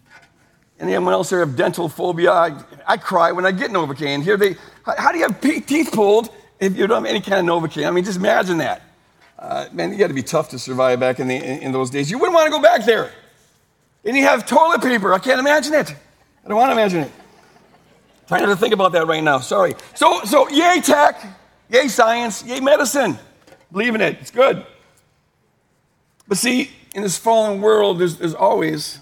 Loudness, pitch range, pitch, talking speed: -17 LUFS, 160-255 Hz, 200 Hz, 215 wpm